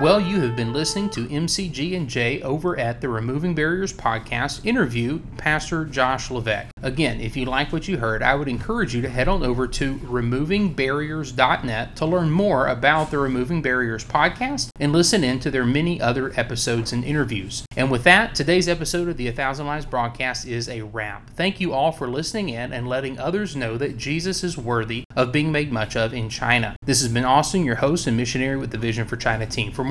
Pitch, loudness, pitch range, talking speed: 130 Hz, -22 LUFS, 120-155 Hz, 210 wpm